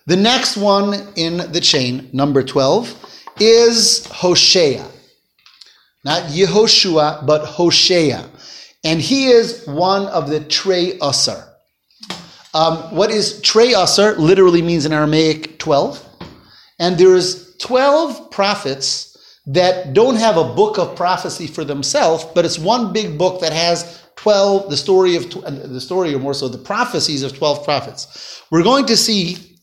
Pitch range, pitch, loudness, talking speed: 155-200 Hz, 175 Hz, -14 LUFS, 140 wpm